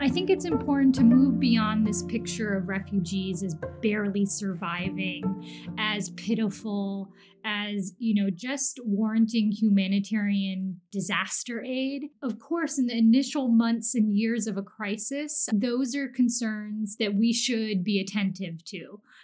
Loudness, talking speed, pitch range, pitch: -26 LUFS, 135 wpm, 195-235 Hz, 215 Hz